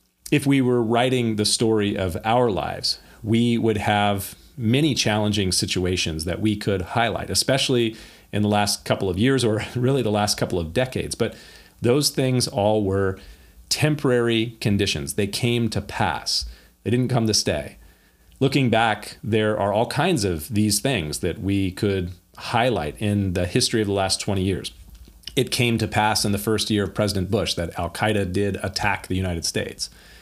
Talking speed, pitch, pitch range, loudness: 175 wpm, 105 Hz, 95-115 Hz, -22 LUFS